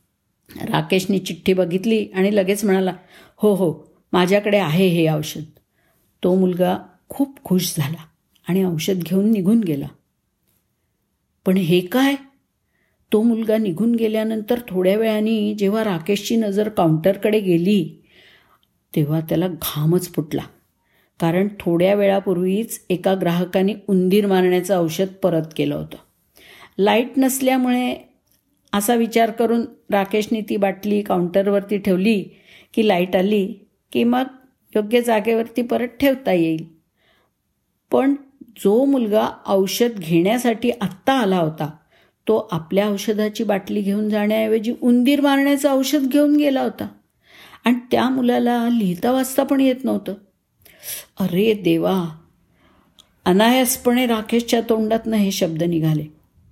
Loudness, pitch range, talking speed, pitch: -19 LUFS, 180-230 Hz, 115 wpm, 205 Hz